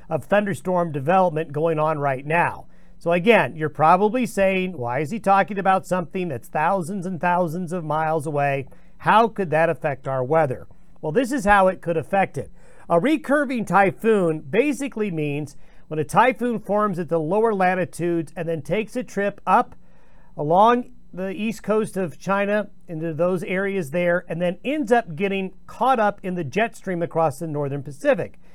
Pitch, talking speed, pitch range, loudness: 180 Hz, 175 wpm, 165-205 Hz, -22 LUFS